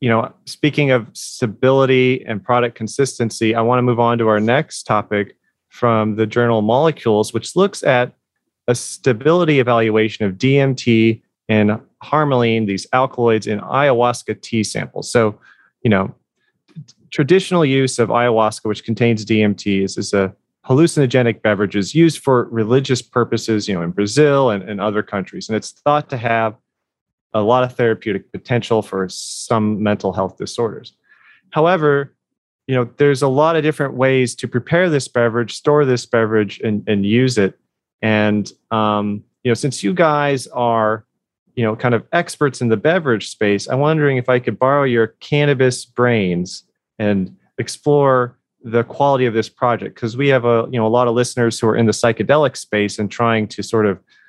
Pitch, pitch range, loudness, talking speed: 120 Hz, 110-130 Hz, -17 LUFS, 170 wpm